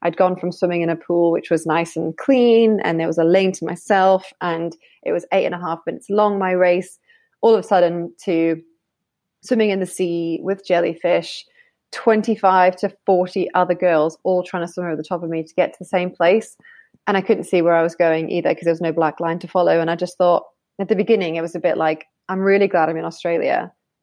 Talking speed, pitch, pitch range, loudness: 240 wpm, 180 Hz, 165-195 Hz, -19 LUFS